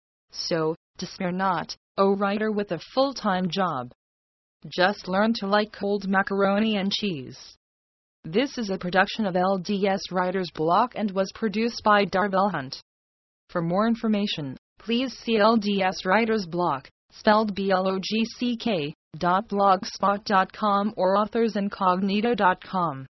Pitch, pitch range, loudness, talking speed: 195 Hz, 175-210 Hz, -24 LUFS, 115 wpm